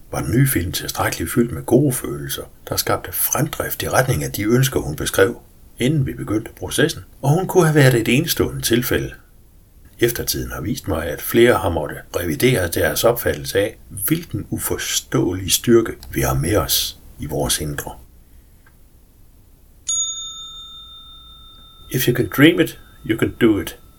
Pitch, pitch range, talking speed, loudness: 135 Hz, 115-185 Hz, 160 wpm, -19 LUFS